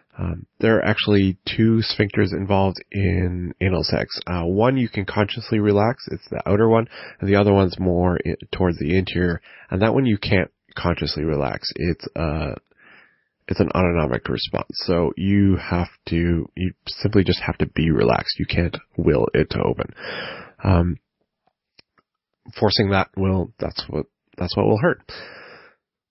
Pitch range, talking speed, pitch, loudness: 85-105 Hz, 155 wpm, 95 Hz, -21 LUFS